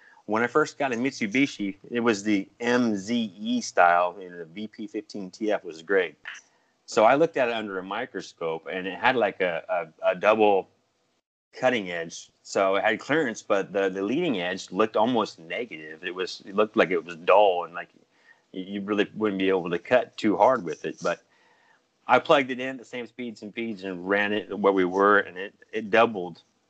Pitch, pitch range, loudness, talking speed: 105 Hz, 95-120 Hz, -25 LUFS, 200 wpm